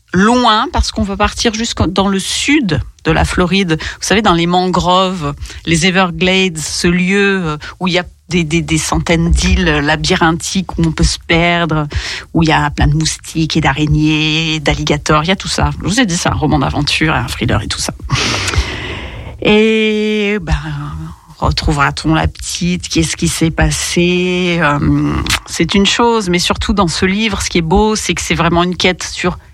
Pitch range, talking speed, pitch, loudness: 155-190 Hz, 190 wpm, 175 Hz, -13 LUFS